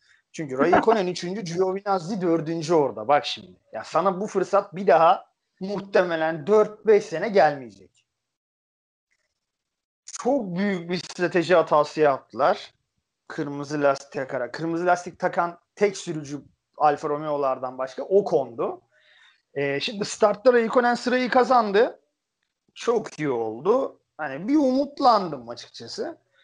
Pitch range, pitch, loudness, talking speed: 150-210 Hz, 180 Hz, -23 LUFS, 115 wpm